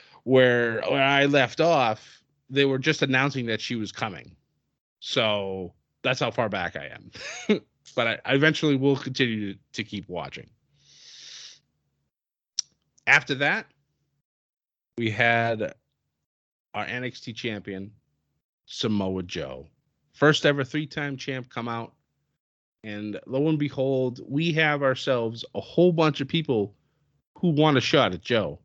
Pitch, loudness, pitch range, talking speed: 130 Hz, -25 LUFS, 110-145 Hz, 135 wpm